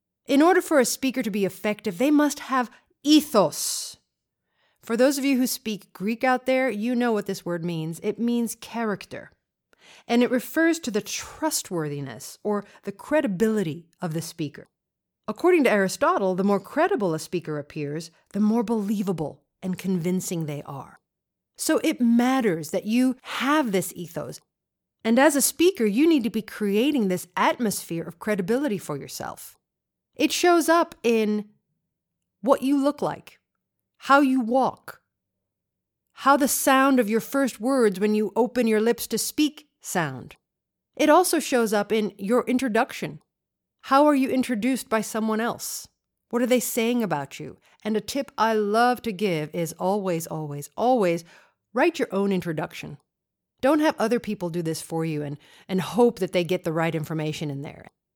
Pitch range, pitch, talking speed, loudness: 185-260 Hz, 220 Hz, 165 wpm, -24 LUFS